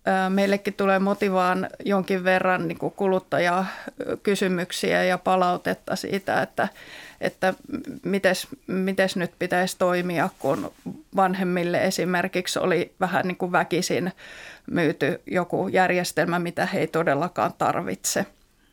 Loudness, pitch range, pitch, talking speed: -24 LUFS, 180-195 Hz, 185 Hz, 105 wpm